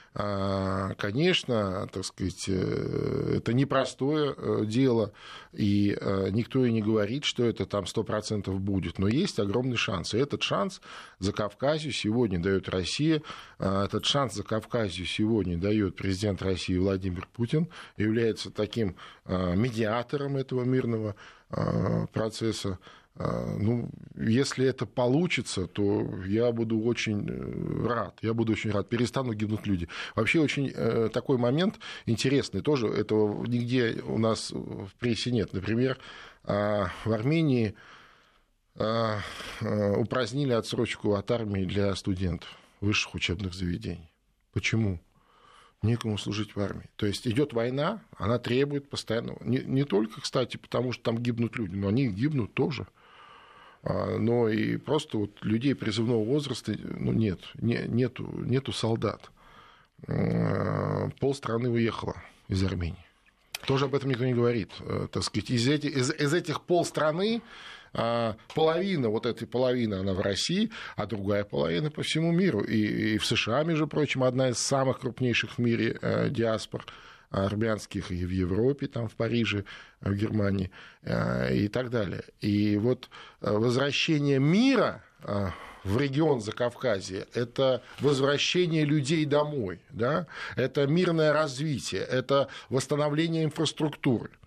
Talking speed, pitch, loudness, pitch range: 125 wpm, 115 Hz, -28 LUFS, 105-135 Hz